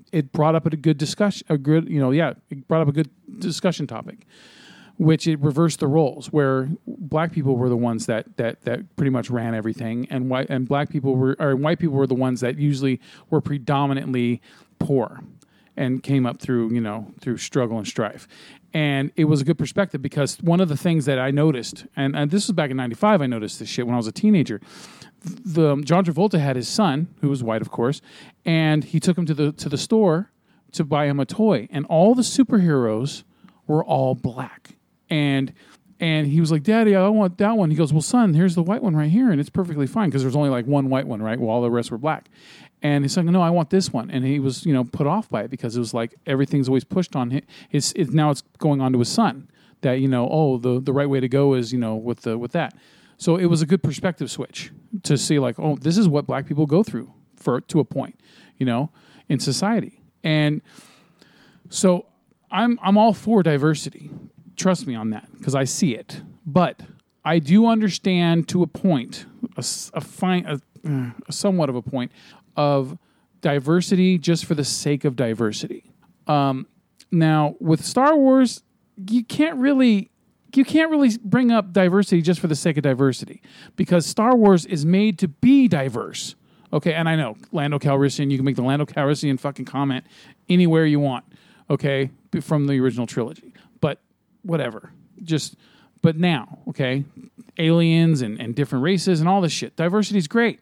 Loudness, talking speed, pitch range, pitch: -21 LUFS, 210 wpm, 135-185 Hz, 155 Hz